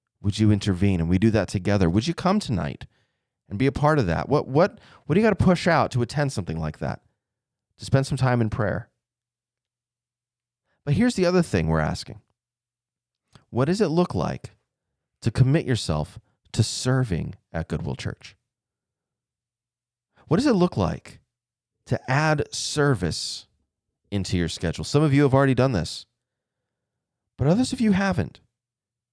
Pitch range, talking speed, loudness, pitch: 105-145 Hz, 165 wpm, -23 LUFS, 120 Hz